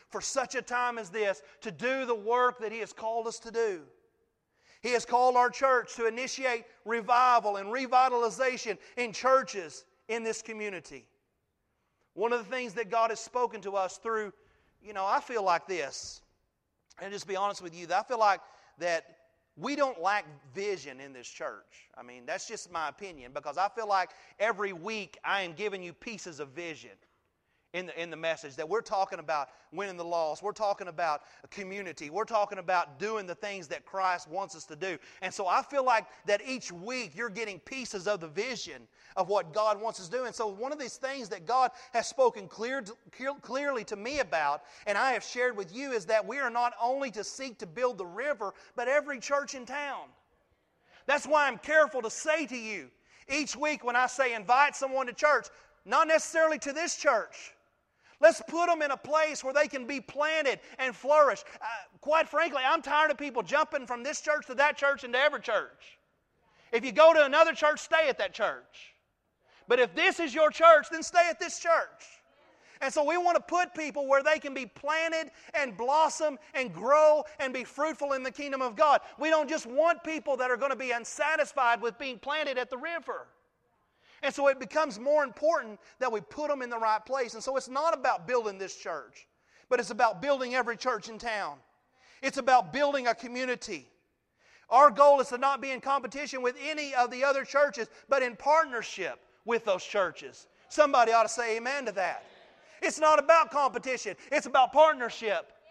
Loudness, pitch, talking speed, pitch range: -29 LUFS, 250 Hz, 205 wpm, 210-285 Hz